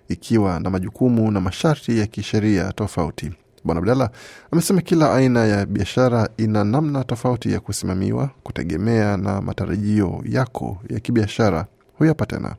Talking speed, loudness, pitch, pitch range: 130 wpm, -20 LUFS, 110 Hz, 100-125 Hz